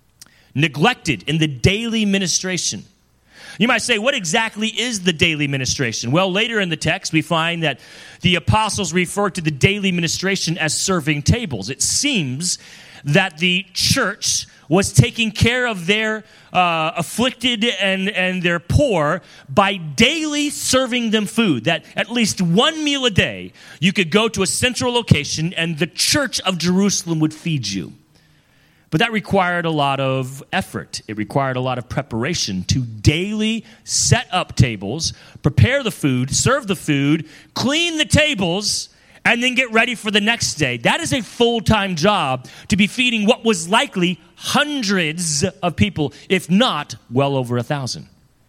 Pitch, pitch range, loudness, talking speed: 180 Hz, 150-220 Hz, -18 LUFS, 160 wpm